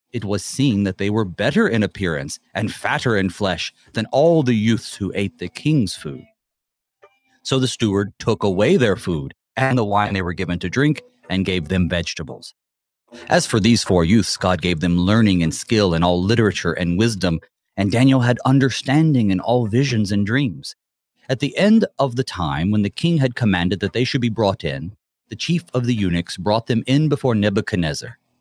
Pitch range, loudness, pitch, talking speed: 95-130 Hz, -19 LUFS, 110 Hz, 195 wpm